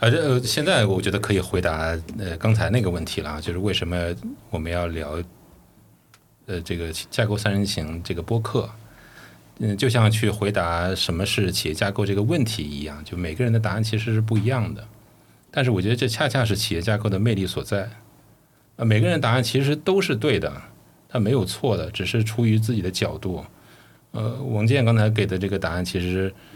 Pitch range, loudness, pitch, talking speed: 90-115 Hz, -23 LUFS, 105 Hz, 295 characters per minute